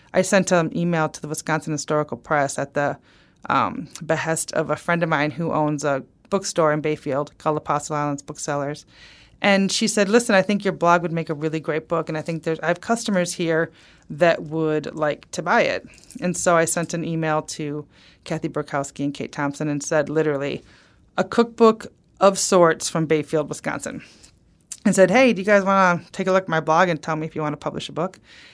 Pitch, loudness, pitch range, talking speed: 160 Hz, -21 LUFS, 150-180 Hz, 215 wpm